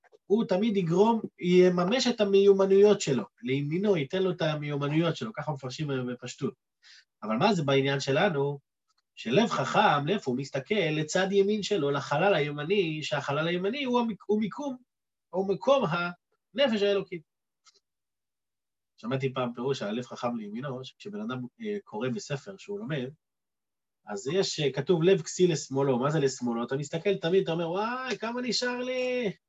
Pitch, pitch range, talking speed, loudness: 185 Hz, 145-210 Hz, 145 wpm, -28 LUFS